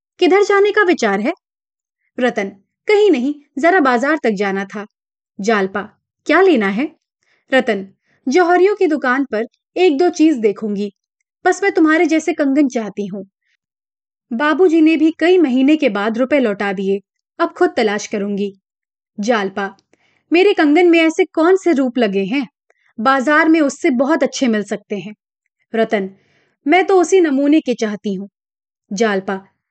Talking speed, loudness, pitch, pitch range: 150 wpm, -15 LUFS, 270 Hz, 210-330 Hz